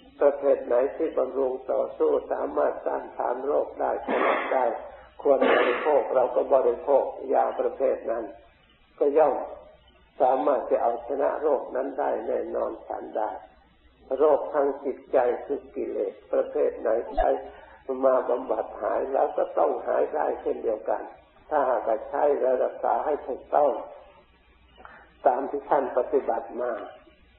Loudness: -26 LUFS